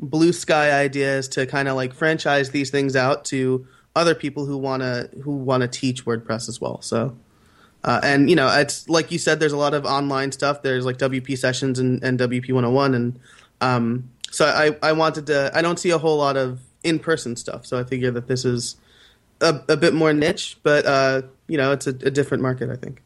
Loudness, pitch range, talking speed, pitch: -21 LUFS, 125-145 Hz, 220 wpm, 135 Hz